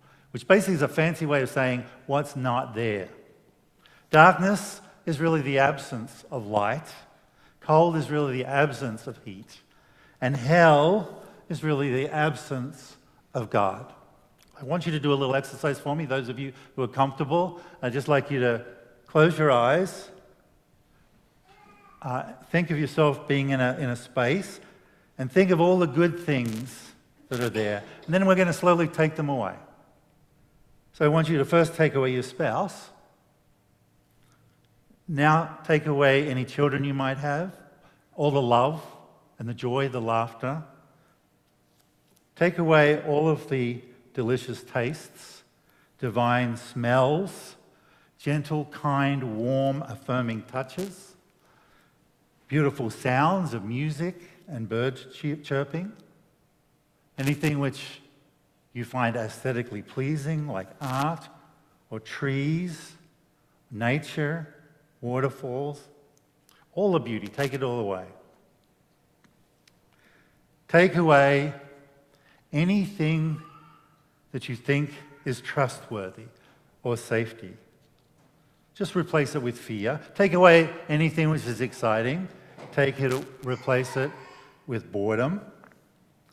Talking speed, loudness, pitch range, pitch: 125 wpm, -25 LUFS, 125-160 Hz, 140 Hz